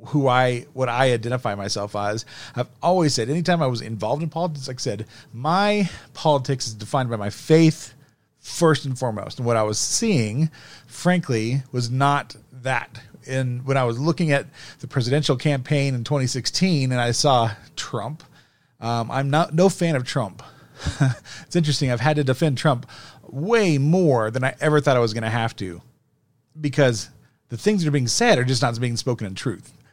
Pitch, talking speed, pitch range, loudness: 135 Hz, 185 wpm, 120-150 Hz, -22 LUFS